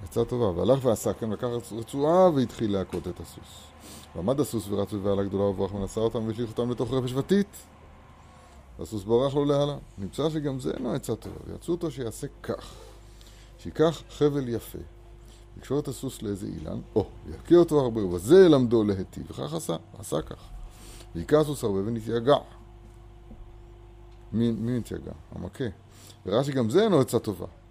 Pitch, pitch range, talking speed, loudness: 115 Hz, 100-125 Hz, 155 wpm, -26 LUFS